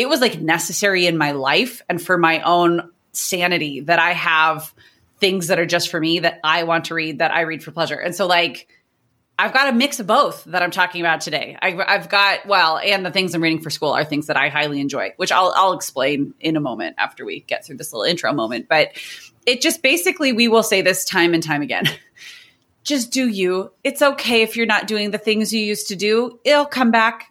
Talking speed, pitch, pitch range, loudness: 235 wpm, 185 Hz, 165-225 Hz, -18 LUFS